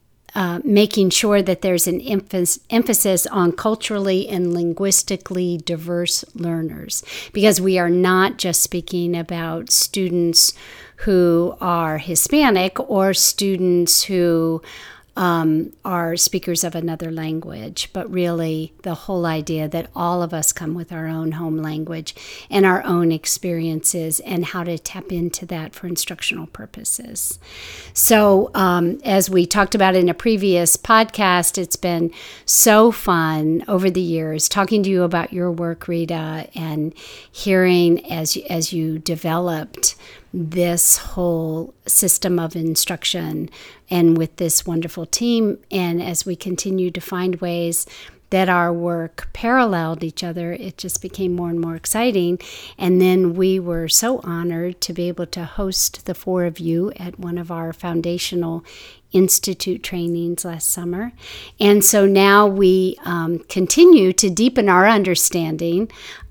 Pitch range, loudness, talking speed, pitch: 170-190 Hz, -18 LUFS, 140 wpm, 175 Hz